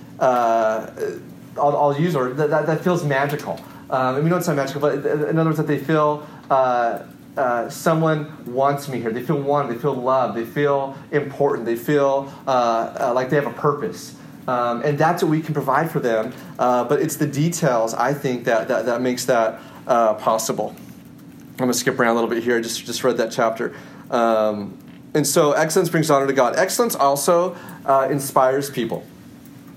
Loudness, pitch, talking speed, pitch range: -20 LUFS, 140 Hz, 200 wpm, 125-150 Hz